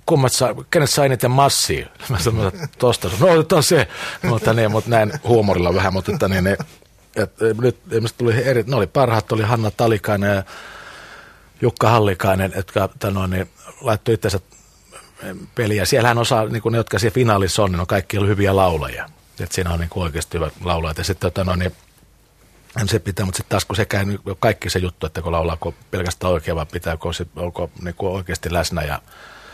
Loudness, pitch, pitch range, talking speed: -19 LUFS, 100 Hz, 90-115 Hz, 175 wpm